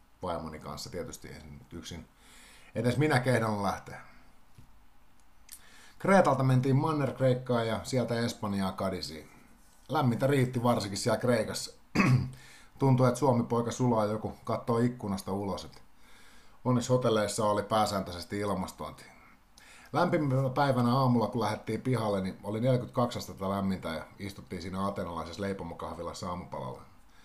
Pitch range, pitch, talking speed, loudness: 95-125 Hz, 110 Hz, 115 wpm, -30 LUFS